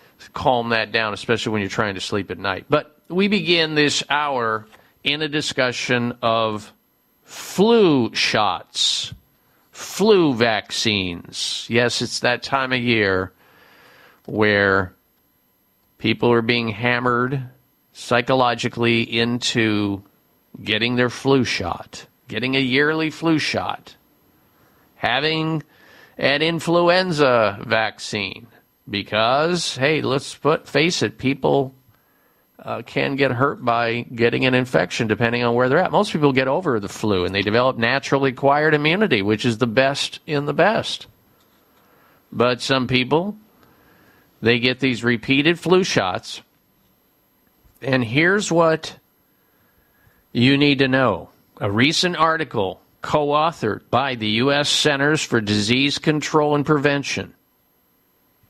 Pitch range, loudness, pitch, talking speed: 115-145 Hz, -19 LUFS, 125 Hz, 120 wpm